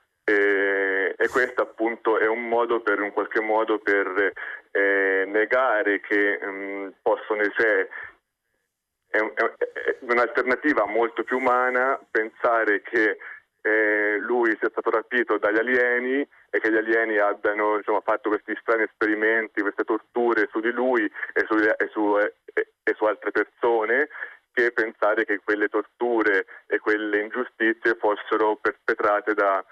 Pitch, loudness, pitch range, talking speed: 110 Hz, -23 LUFS, 100-120 Hz, 135 wpm